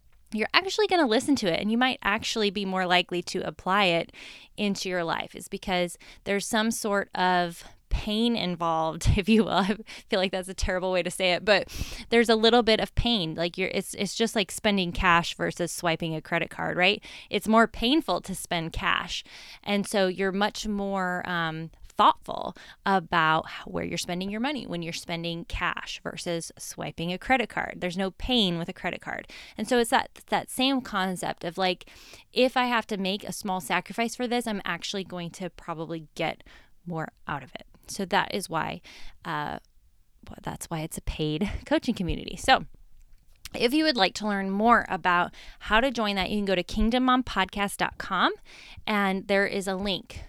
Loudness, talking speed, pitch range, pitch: -27 LUFS, 195 wpm, 175-220 Hz, 195 Hz